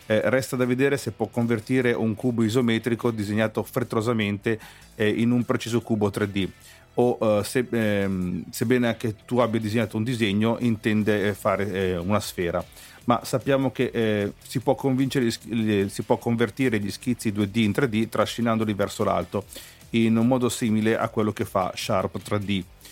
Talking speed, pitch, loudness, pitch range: 160 wpm, 115 Hz, -24 LUFS, 105-120 Hz